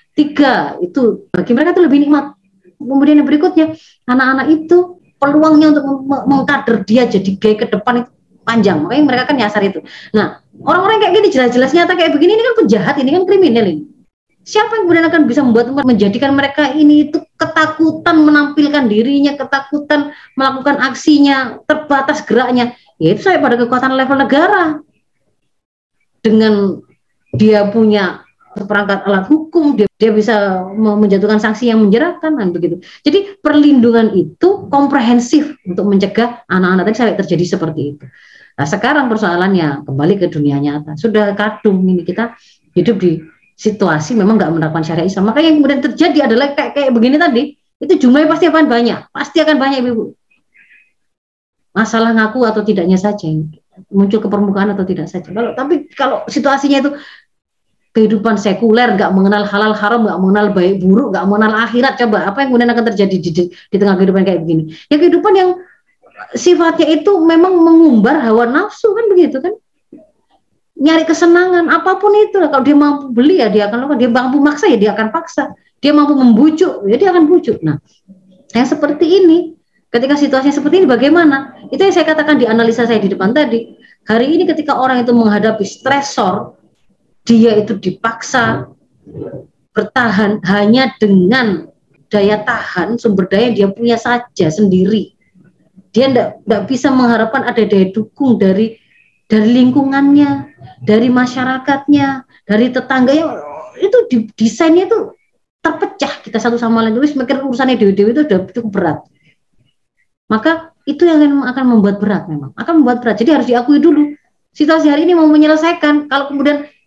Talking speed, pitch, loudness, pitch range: 160 wpm, 250 Hz, -12 LUFS, 210-295 Hz